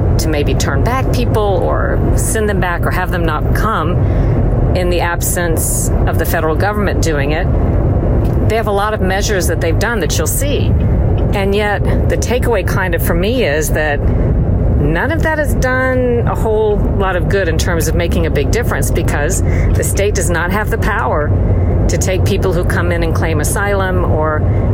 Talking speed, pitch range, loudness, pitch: 195 wpm, 90-110 Hz, -14 LUFS, 100 Hz